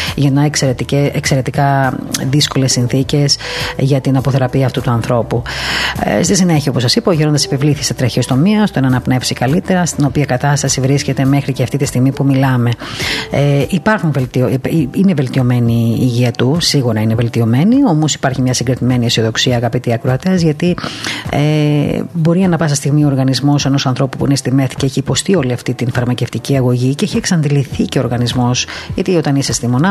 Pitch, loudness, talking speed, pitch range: 135 Hz, -13 LUFS, 175 wpm, 125-150 Hz